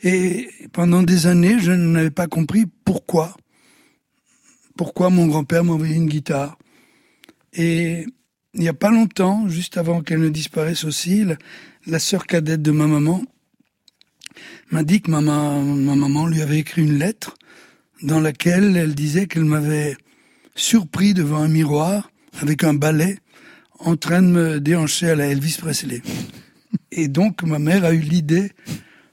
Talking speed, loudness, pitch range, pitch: 155 wpm, -18 LUFS, 155-185 Hz, 165 Hz